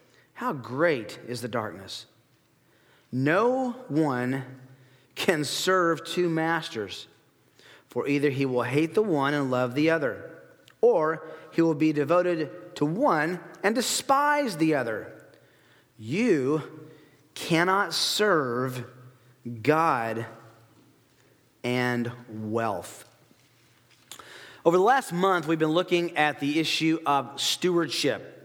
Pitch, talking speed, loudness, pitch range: 155 Hz, 110 wpm, -26 LUFS, 130-170 Hz